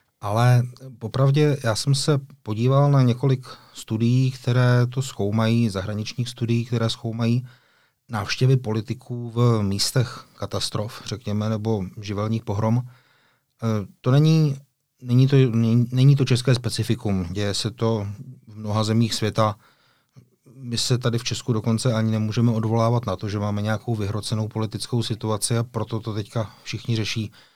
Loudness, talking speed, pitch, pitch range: -23 LUFS, 135 wpm, 115 Hz, 110-125 Hz